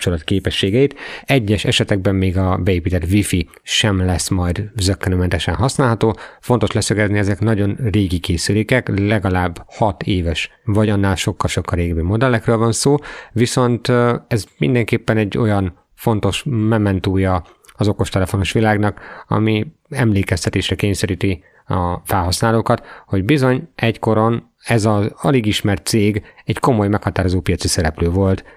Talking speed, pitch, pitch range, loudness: 120 wpm, 105 Hz, 95-115 Hz, -17 LUFS